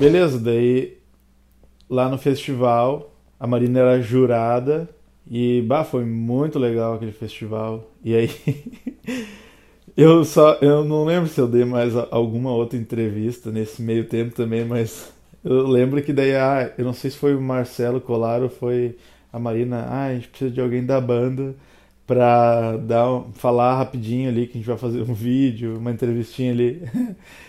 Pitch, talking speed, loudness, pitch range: 125 Hz, 160 wpm, -20 LUFS, 115-135 Hz